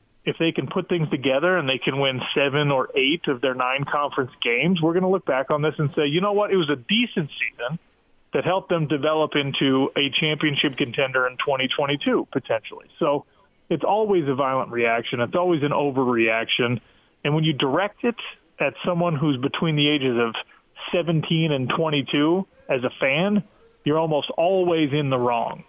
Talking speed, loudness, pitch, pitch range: 185 wpm, -22 LUFS, 150 Hz, 135-175 Hz